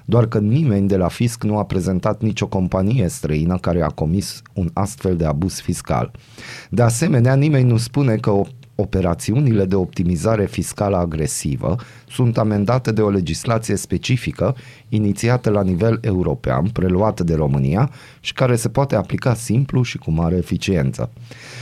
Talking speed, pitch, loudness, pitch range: 150 wpm, 105 Hz, -19 LUFS, 90-125 Hz